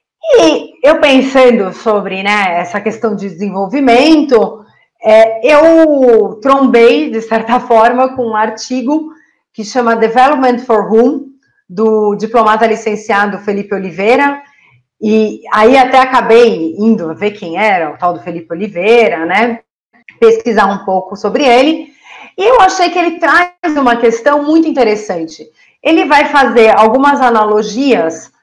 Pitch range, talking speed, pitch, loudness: 210-270 Hz, 130 wpm, 230 Hz, -10 LUFS